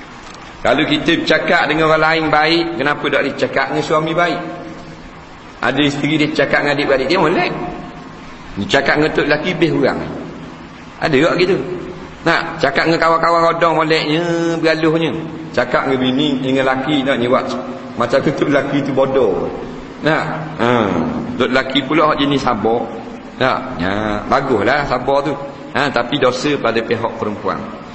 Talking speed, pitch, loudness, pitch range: 155 wpm, 145 Hz, -15 LUFS, 130-160 Hz